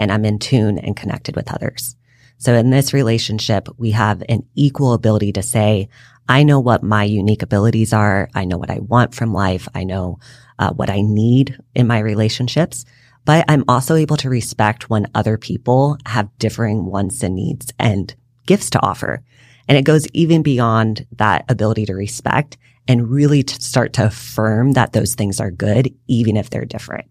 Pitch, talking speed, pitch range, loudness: 115 Hz, 185 wpm, 105-130 Hz, -16 LUFS